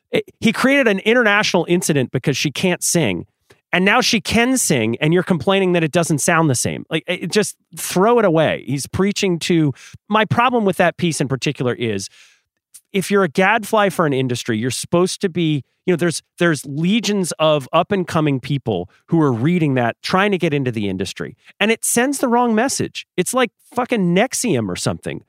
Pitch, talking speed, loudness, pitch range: 175 Hz, 195 wpm, -18 LUFS, 150-205 Hz